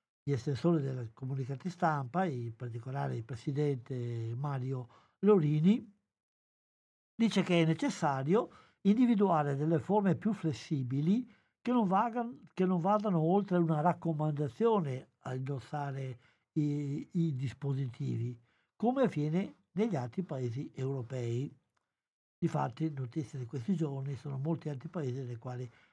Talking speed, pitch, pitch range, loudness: 120 wpm, 150 Hz, 135-180 Hz, -33 LUFS